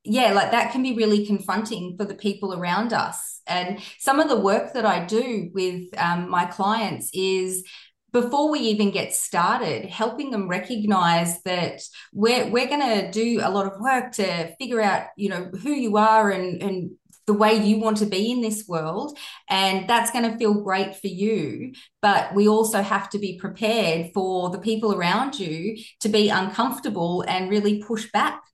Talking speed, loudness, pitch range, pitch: 185 wpm, -23 LUFS, 190-225 Hz, 205 Hz